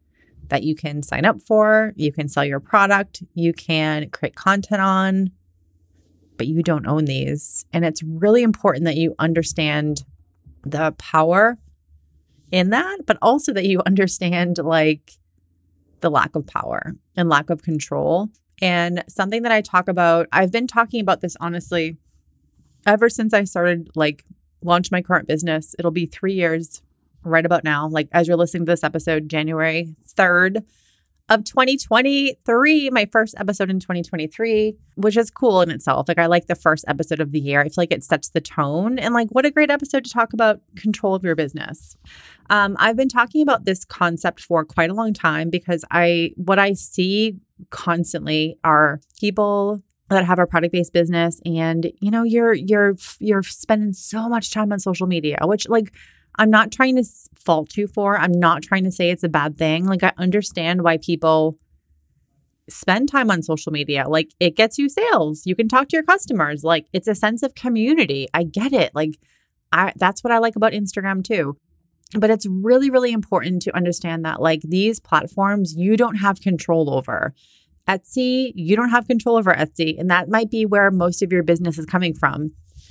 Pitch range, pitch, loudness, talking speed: 160-210 Hz, 175 Hz, -19 LUFS, 185 wpm